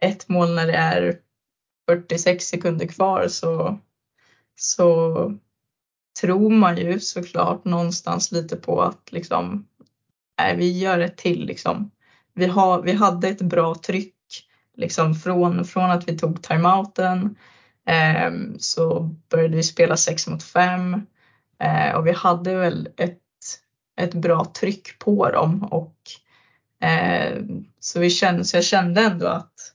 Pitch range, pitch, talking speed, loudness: 170-185 Hz, 175 Hz, 135 wpm, -21 LUFS